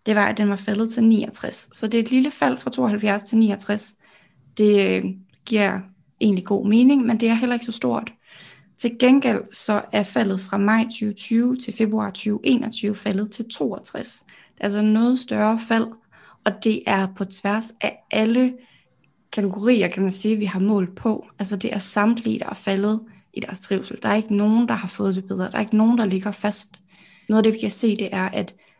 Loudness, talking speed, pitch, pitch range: -21 LUFS, 210 wpm, 210 Hz, 200-225 Hz